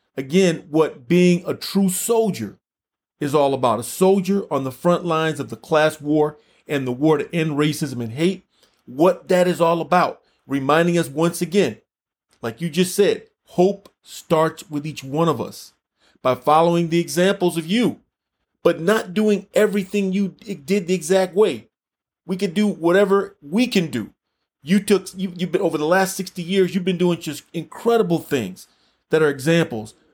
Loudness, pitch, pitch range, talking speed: -20 LUFS, 175 Hz, 155-195 Hz, 175 wpm